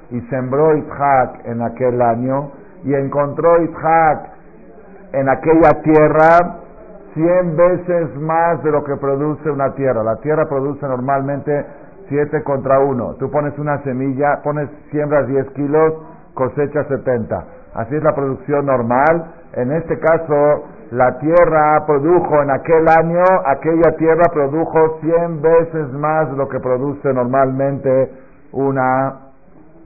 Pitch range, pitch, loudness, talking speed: 135-160 Hz, 145 Hz, -15 LUFS, 130 wpm